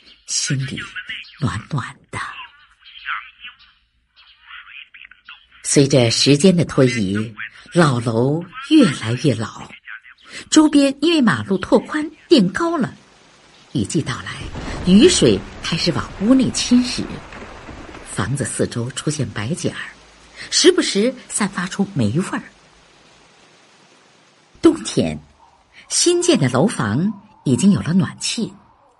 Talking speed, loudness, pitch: 150 characters per minute, -18 LUFS, 175 Hz